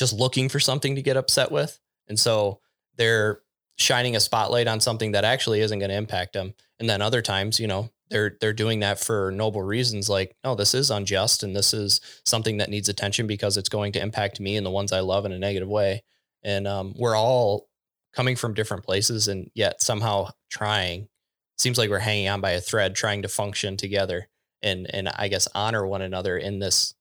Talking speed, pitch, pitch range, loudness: 215 wpm, 105 Hz, 100-115 Hz, -24 LUFS